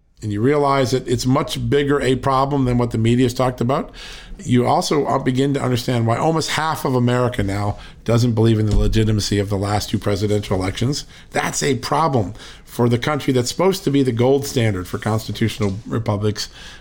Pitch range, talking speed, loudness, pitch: 105-135 Hz, 195 wpm, -19 LUFS, 125 Hz